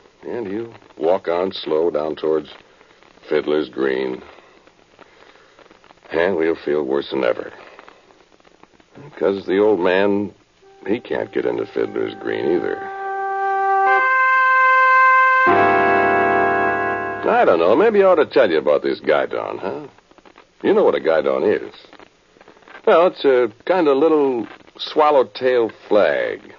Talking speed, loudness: 120 wpm, -17 LUFS